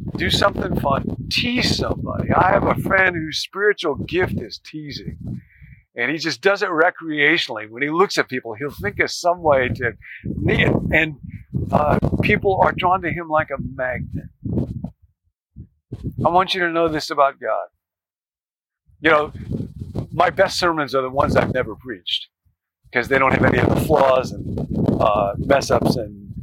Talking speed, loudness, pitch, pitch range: 170 wpm, -19 LUFS, 145 Hz, 125-170 Hz